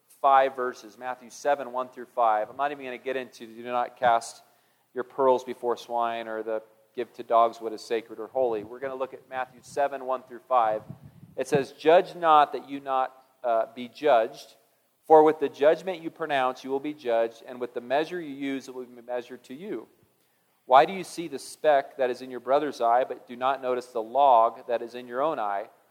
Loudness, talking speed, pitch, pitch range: -26 LUFS, 225 wpm, 125 Hz, 120-140 Hz